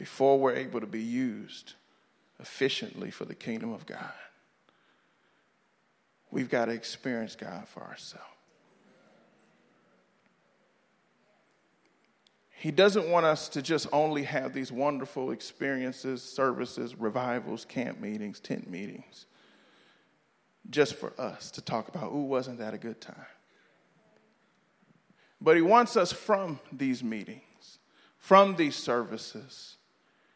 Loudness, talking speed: -30 LUFS, 115 wpm